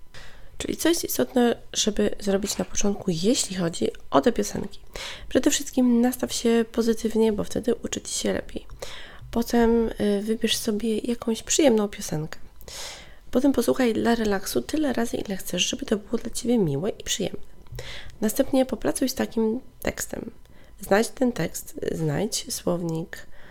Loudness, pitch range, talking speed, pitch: -25 LUFS, 205-255 Hz, 145 wpm, 230 Hz